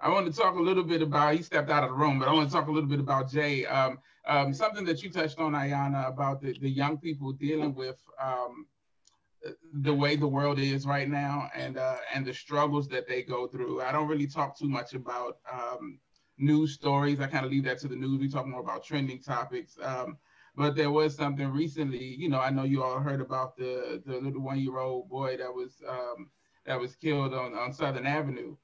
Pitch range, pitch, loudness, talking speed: 130-150 Hz, 140 Hz, -30 LUFS, 230 wpm